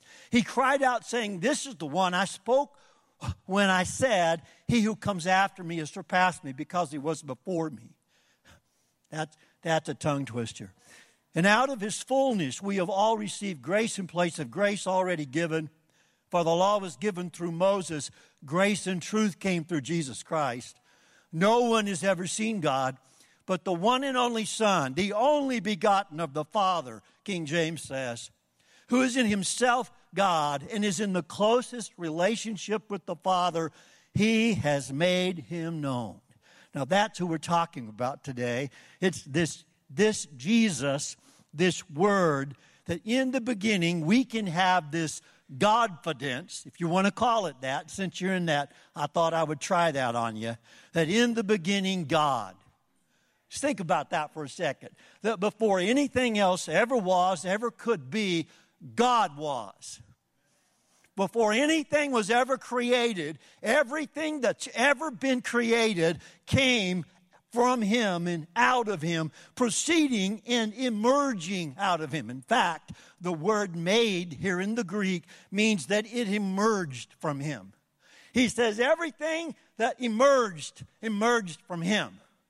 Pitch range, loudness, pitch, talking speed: 165-225 Hz, -28 LUFS, 190 Hz, 155 wpm